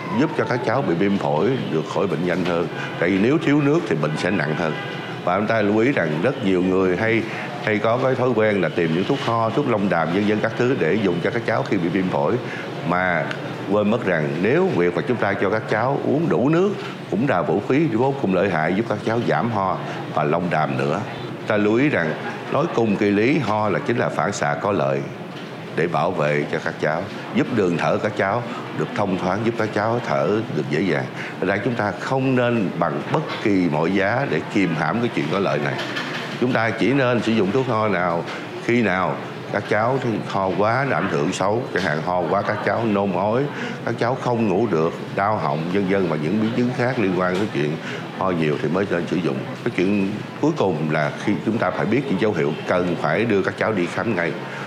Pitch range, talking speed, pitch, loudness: 85-115 Hz, 240 wpm, 105 Hz, -21 LUFS